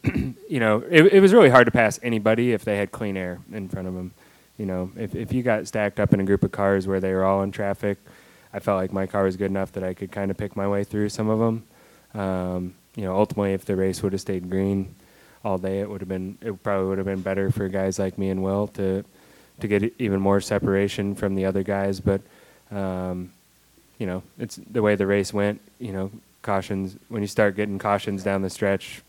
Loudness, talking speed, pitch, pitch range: -23 LUFS, 245 wpm, 100 Hz, 95-105 Hz